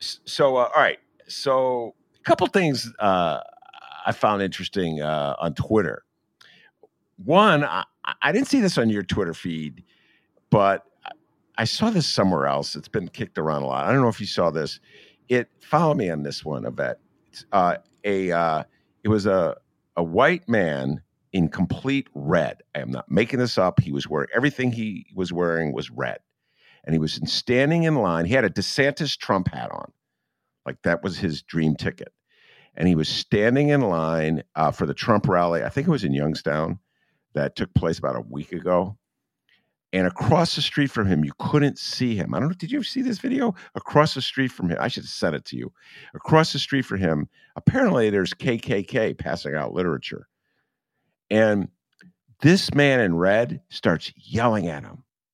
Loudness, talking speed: -23 LUFS, 185 wpm